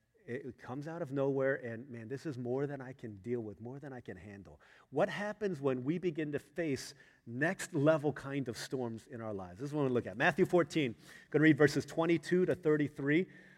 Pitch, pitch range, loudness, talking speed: 140 Hz, 125-160 Hz, -34 LUFS, 225 wpm